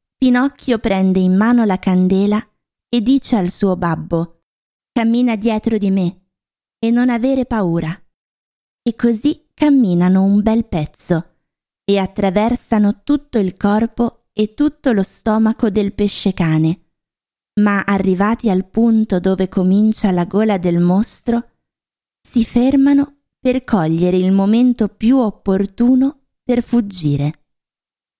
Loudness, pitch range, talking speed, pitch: -16 LUFS, 185-235 Hz, 120 wpm, 210 Hz